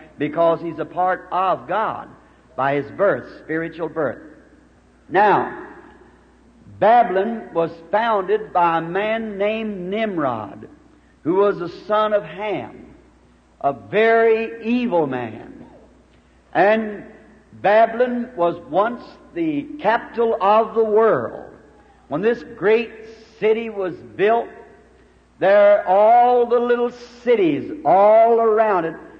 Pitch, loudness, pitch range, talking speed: 215 Hz, -19 LUFS, 175-230 Hz, 110 wpm